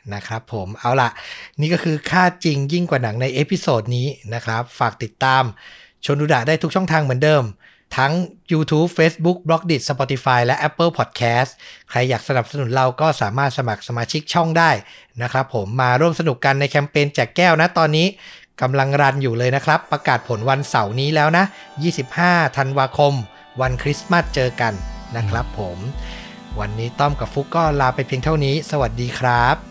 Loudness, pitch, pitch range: -19 LUFS, 140 Hz, 125-155 Hz